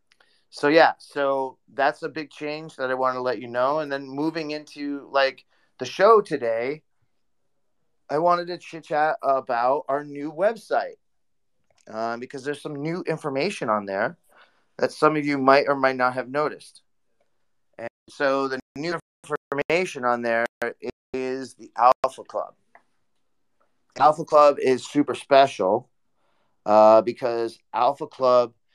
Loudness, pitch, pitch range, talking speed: -23 LUFS, 140 Hz, 125-150 Hz, 145 wpm